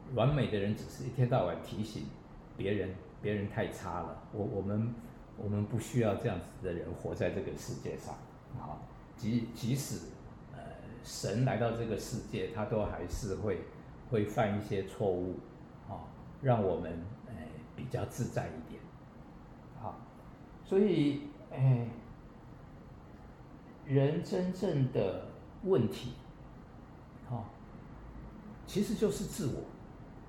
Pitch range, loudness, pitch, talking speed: 105-135 Hz, -35 LUFS, 120 Hz, 185 characters per minute